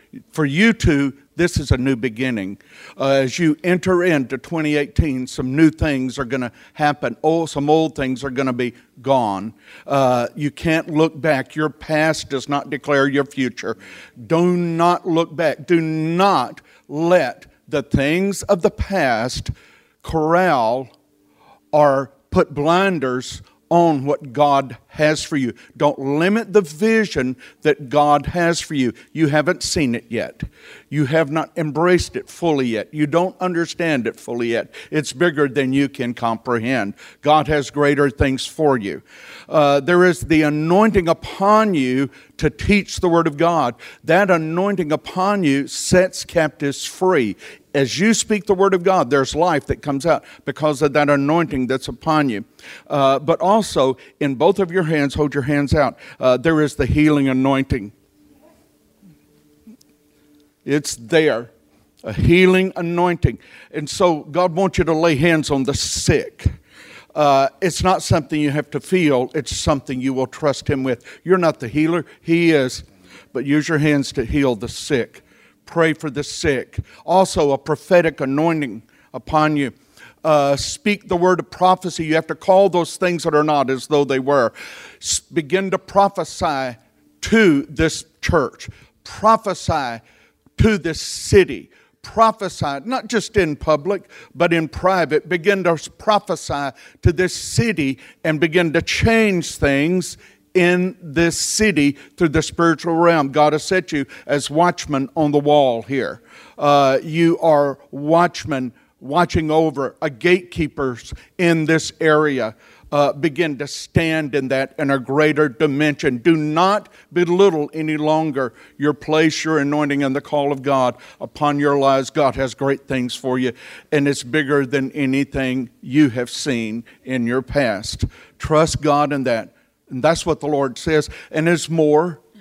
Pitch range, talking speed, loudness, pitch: 135-170 Hz, 160 wpm, -18 LUFS, 150 Hz